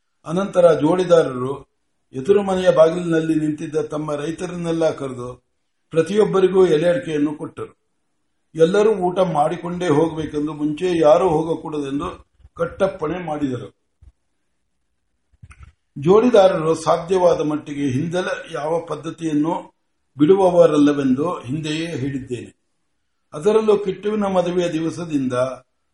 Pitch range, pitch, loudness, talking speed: 145-175 Hz, 160 Hz, -19 LUFS, 80 wpm